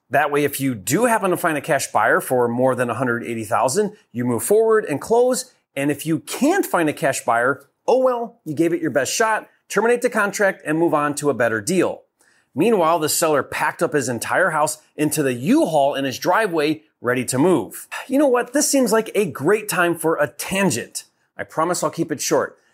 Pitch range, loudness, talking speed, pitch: 140-215 Hz, -20 LUFS, 215 wpm, 160 Hz